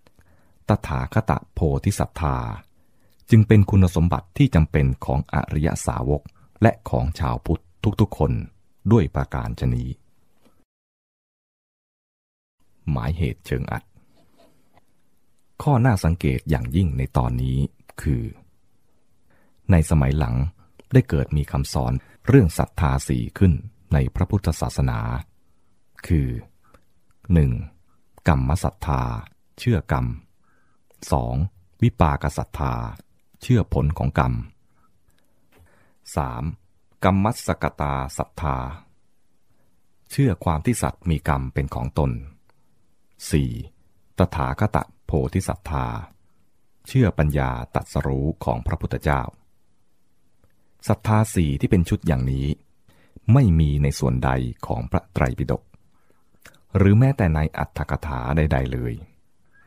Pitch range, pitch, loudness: 70-95 Hz, 80 Hz, -22 LUFS